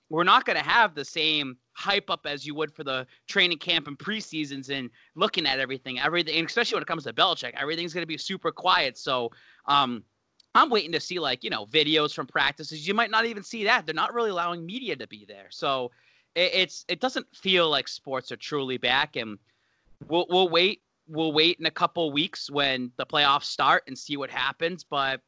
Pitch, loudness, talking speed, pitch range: 155 Hz, -25 LUFS, 215 wpm, 135-180 Hz